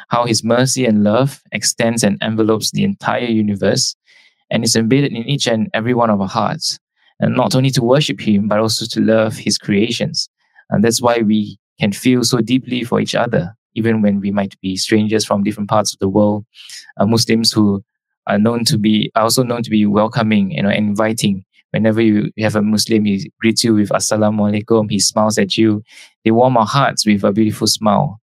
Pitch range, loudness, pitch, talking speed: 105-120 Hz, -15 LUFS, 110 Hz, 205 wpm